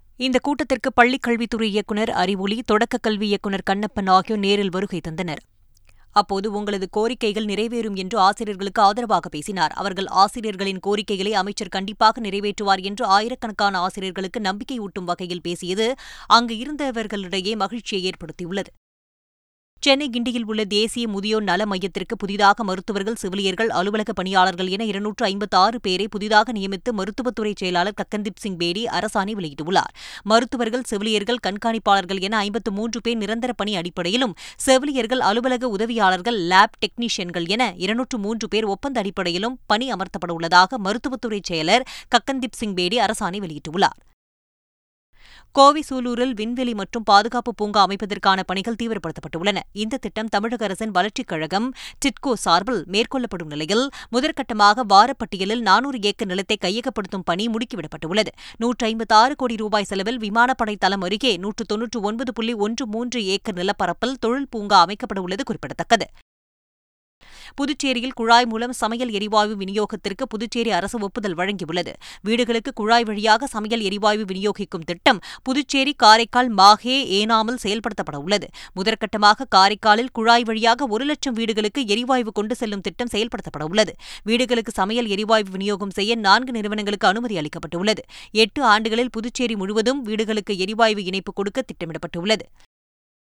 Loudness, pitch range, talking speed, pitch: -21 LUFS, 195-235 Hz, 125 wpm, 215 Hz